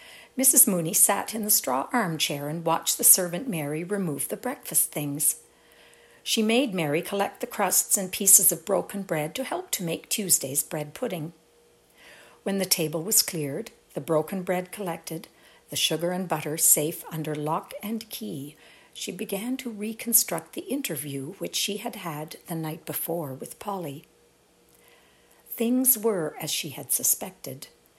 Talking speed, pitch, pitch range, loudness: 155 wpm, 175 Hz, 160-220 Hz, -24 LUFS